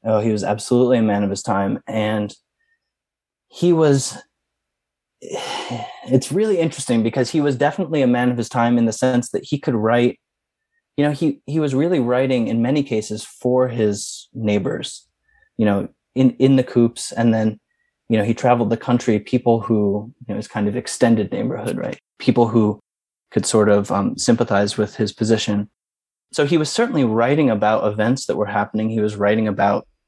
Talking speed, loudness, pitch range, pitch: 185 wpm, -19 LUFS, 105-130 Hz, 115 Hz